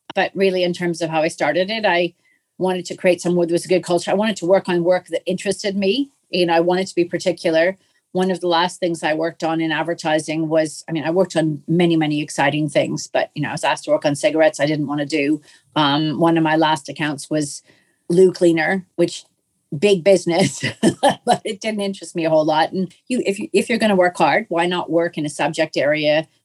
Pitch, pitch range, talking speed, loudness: 170 Hz, 155-185 Hz, 230 wpm, -19 LUFS